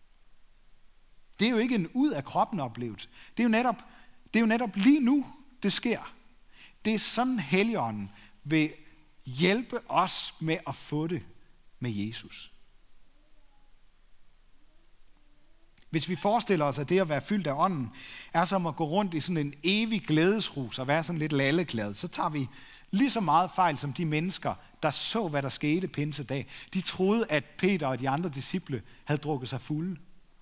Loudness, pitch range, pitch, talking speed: -29 LUFS, 140-205 Hz, 165 Hz, 175 wpm